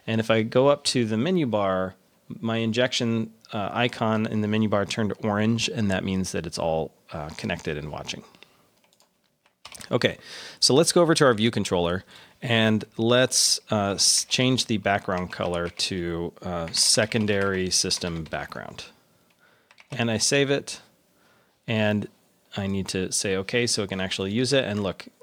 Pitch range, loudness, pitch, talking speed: 95-115 Hz, -24 LUFS, 105 Hz, 160 wpm